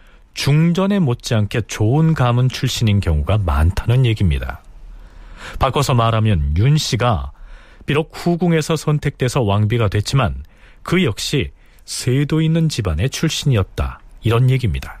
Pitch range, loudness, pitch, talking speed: 100-145 Hz, -17 LUFS, 120 Hz, 290 characters per minute